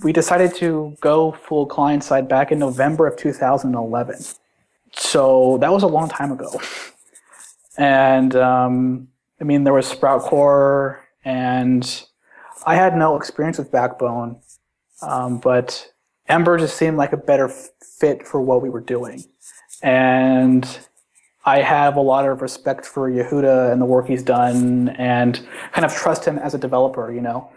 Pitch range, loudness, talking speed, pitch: 125-145 Hz, -18 LUFS, 155 wpm, 135 Hz